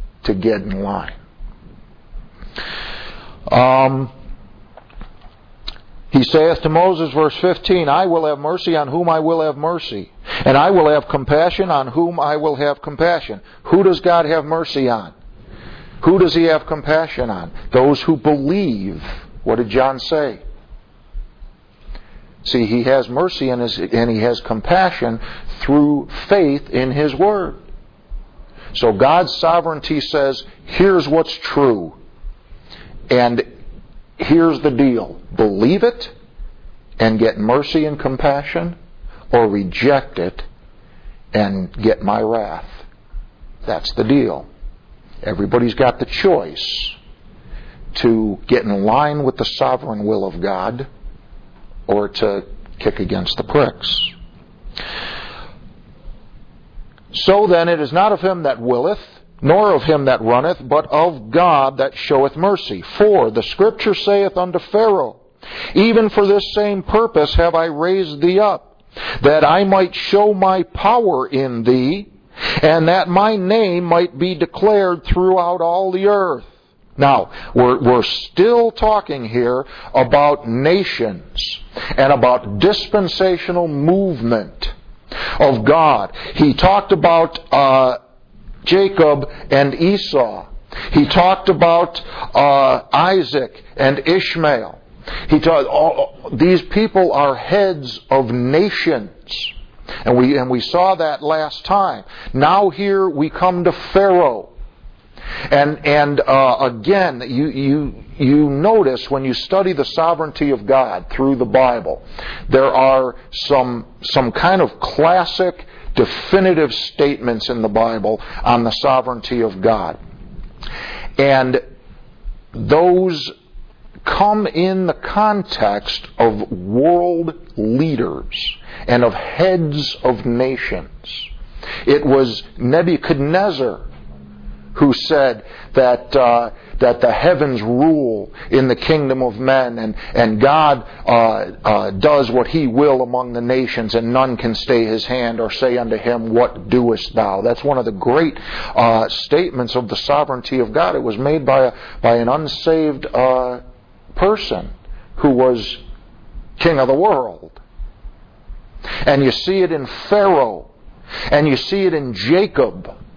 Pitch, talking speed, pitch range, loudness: 145 Hz, 130 wpm, 125-175 Hz, -15 LUFS